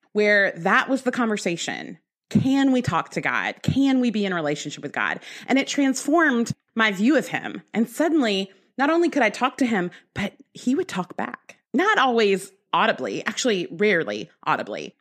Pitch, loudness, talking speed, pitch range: 230 Hz, -22 LUFS, 180 wpm, 195-270 Hz